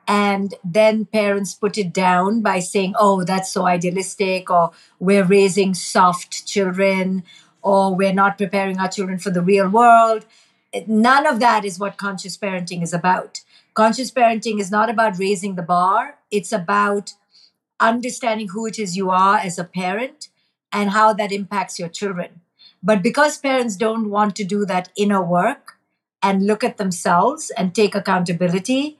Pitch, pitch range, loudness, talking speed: 200 Hz, 185-220 Hz, -18 LUFS, 160 wpm